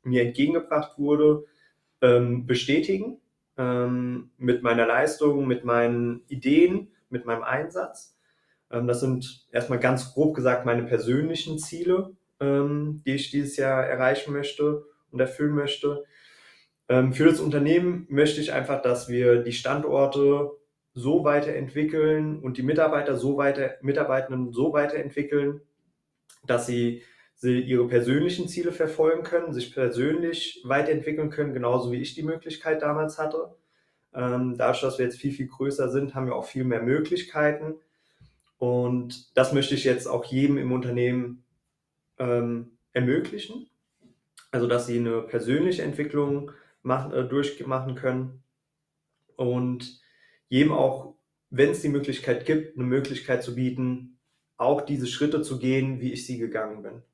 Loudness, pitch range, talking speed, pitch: -25 LUFS, 125-150 Hz, 130 wpm, 135 Hz